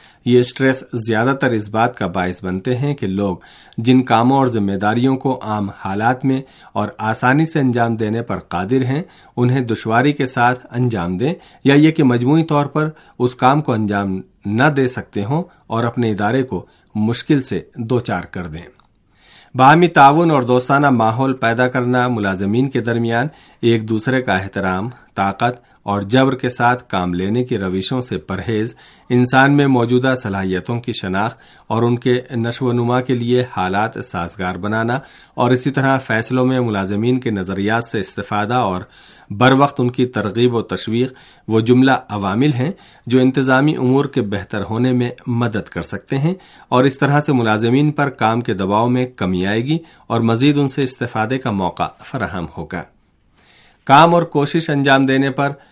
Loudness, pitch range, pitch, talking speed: -17 LUFS, 105-130 Hz, 120 Hz, 175 wpm